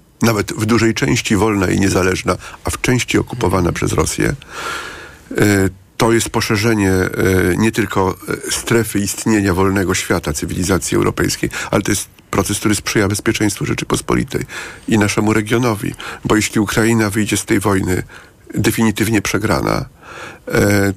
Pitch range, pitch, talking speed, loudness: 95-110 Hz, 105 Hz, 130 wpm, -16 LUFS